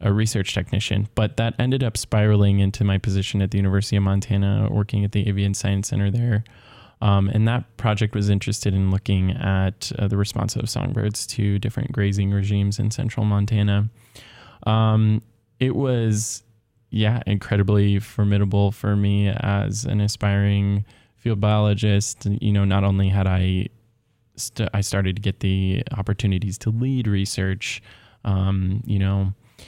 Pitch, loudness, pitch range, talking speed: 105 Hz, -22 LUFS, 100-115 Hz, 155 wpm